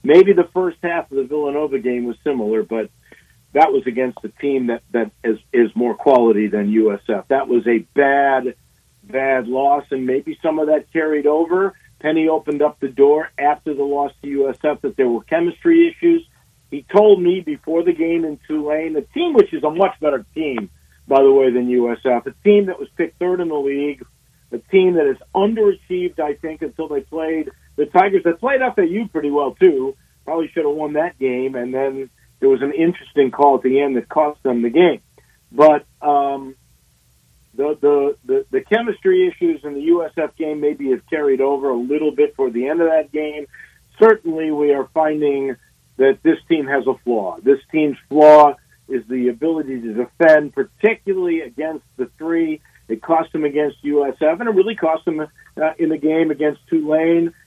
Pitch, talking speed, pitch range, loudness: 150 Hz, 195 wpm, 135-170 Hz, -17 LUFS